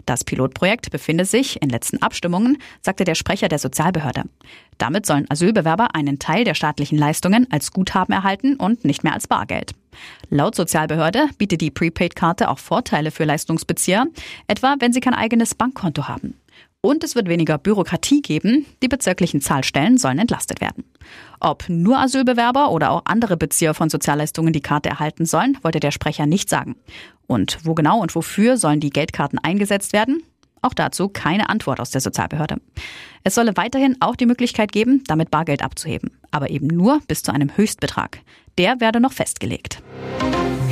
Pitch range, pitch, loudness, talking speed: 155-230 Hz, 175 Hz, -19 LUFS, 165 wpm